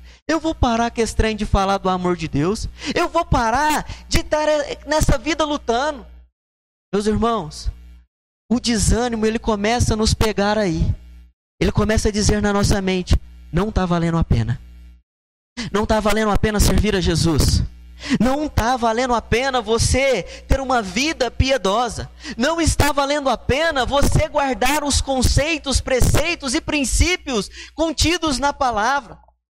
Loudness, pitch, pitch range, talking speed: -19 LUFS, 230 Hz, 175-285 Hz, 155 wpm